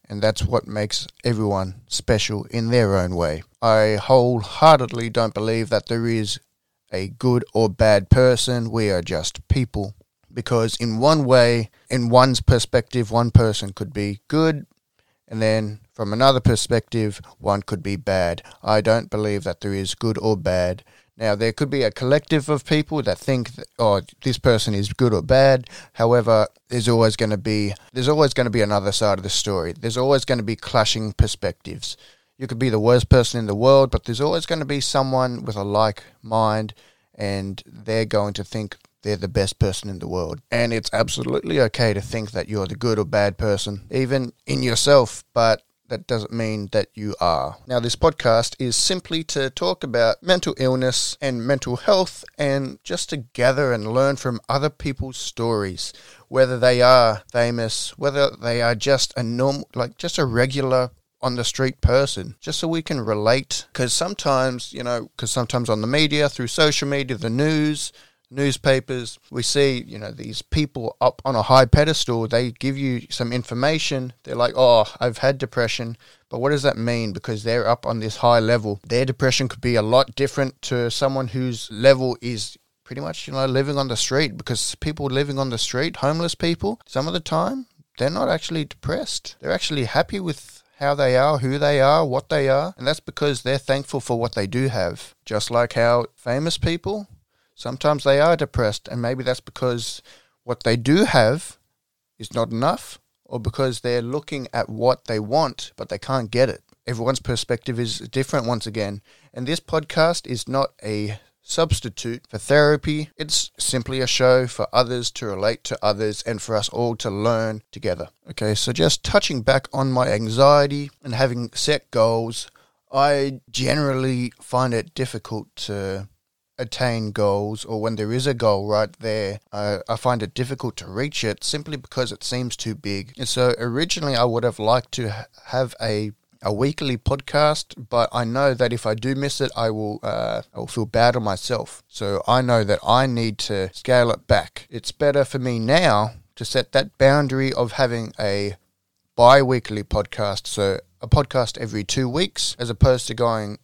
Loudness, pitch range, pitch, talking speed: -21 LUFS, 110-135 Hz, 120 Hz, 185 wpm